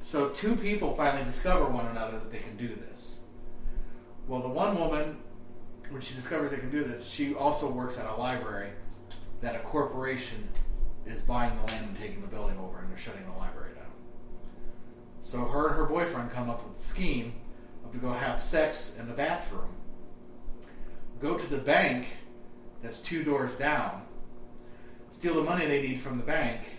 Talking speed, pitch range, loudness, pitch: 180 wpm, 115-140 Hz, -32 LUFS, 120 Hz